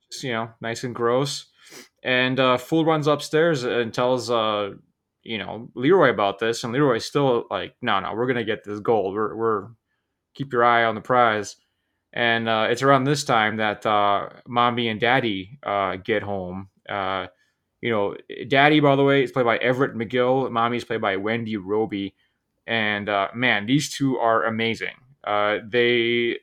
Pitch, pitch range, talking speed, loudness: 115 Hz, 105-130 Hz, 175 wpm, -22 LUFS